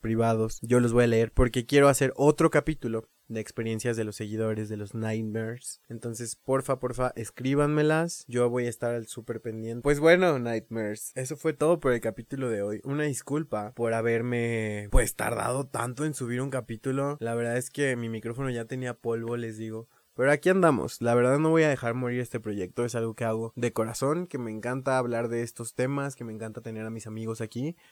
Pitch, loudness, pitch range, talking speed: 120 Hz, -28 LUFS, 115-135 Hz, 205 wpm